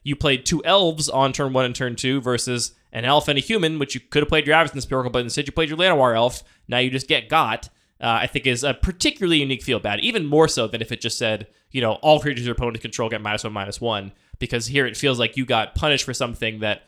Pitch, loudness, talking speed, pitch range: 130 Hz, -21 LUFS, 270 wpm, 115-145 Hz